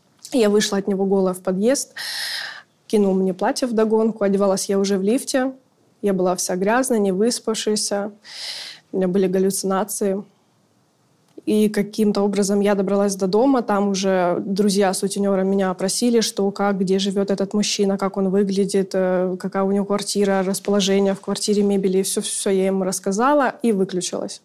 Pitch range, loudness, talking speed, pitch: 195-215 Hz, -20 LUFS, 160 wpm, 200 Hz